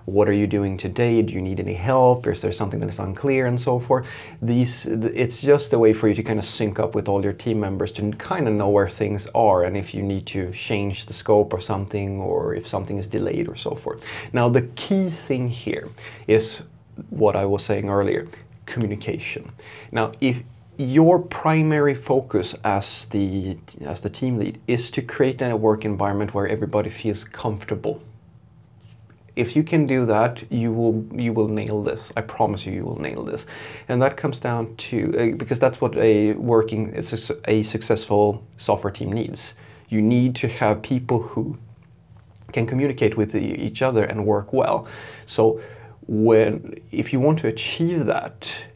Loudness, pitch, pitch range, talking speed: -22 LUFS, 110 Hz, 105-125 Hz, 185 wpm